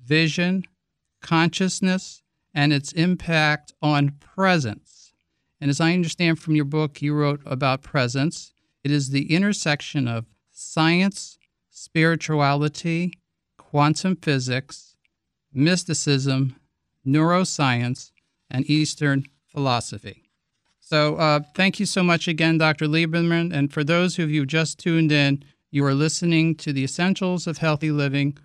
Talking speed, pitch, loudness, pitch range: 125 wpm, 150 Hz, -22 LUFS, 140-170 Hz